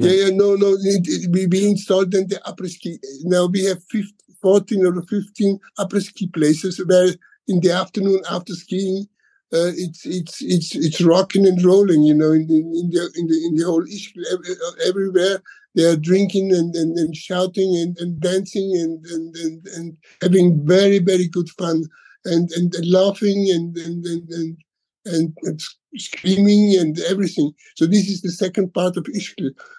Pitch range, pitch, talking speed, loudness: 170-195 Hz, 180 Hz, 175 wpm, -18 LUFS